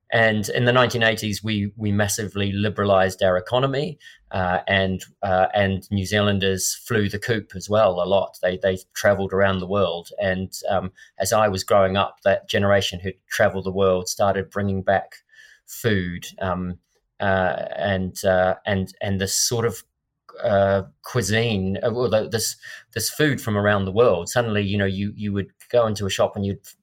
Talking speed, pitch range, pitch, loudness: 175 wpm, 95-110 Hz, 100 Hz, -22 LUFS